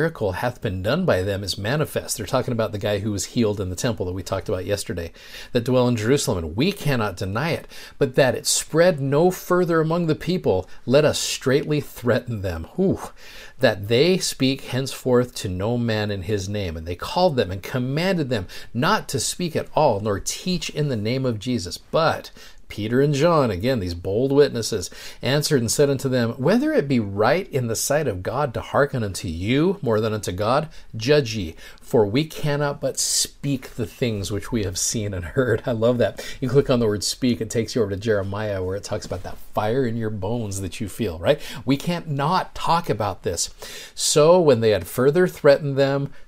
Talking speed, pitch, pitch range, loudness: 210 wpm, 120 Hz, 105-140 Hz, -22 LUFS